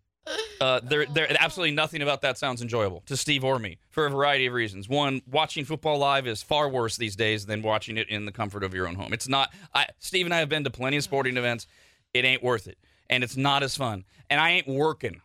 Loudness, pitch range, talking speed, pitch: -26 LUFS, 115-150 Hz, 250 wpm, 135 Hz